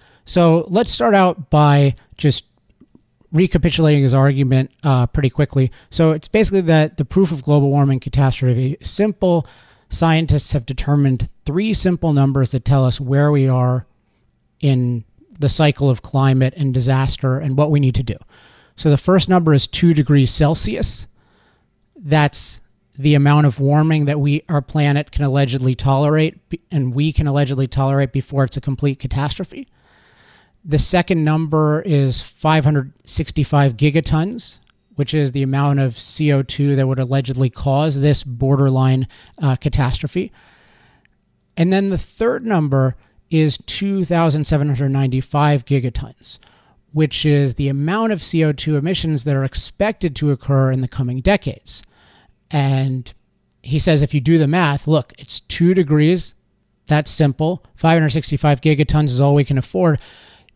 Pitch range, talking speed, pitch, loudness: 135-155 Hz, 145 wpm, 145 Hz, -17 LUFS